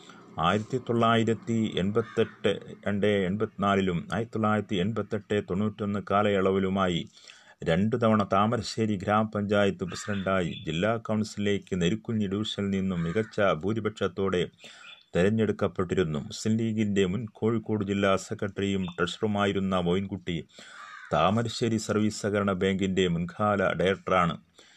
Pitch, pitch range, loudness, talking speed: 105 Hz, 95-110 Hz, -28 LUFS, 90 wpm